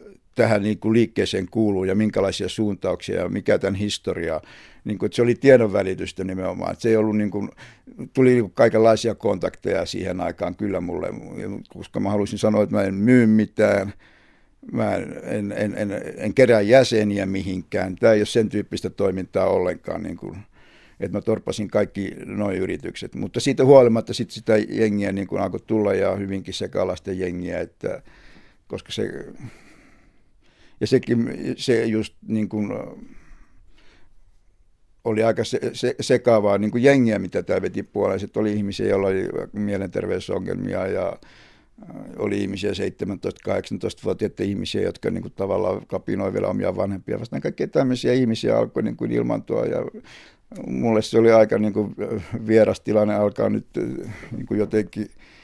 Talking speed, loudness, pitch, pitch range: 135 wpm, -22 LUFS, 105 Hz, 100-115 Hz